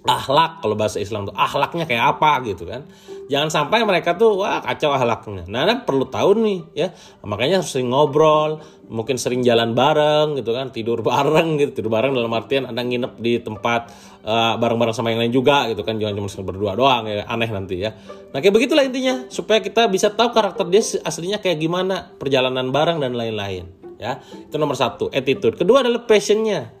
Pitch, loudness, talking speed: 140 Hz, -19 LUFS, 195 wpm